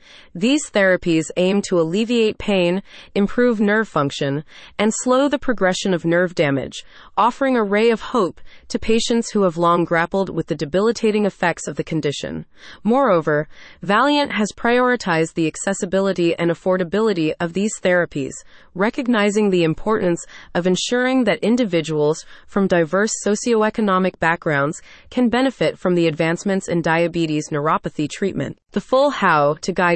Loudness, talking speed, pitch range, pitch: -19 LUFS, 140 wpm, 165-220 Hz, 190 Hz